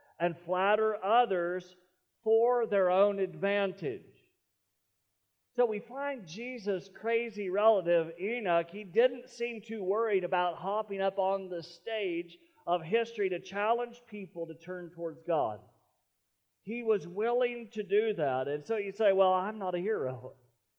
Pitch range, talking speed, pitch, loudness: 175-225 Hz, 140 wpm, 195 Hz, -31 LUFS